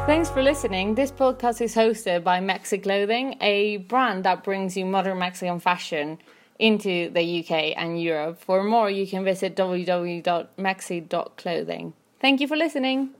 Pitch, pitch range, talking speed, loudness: 195 Hz, 180-235 Hz, 150 wpm, -24 LUFS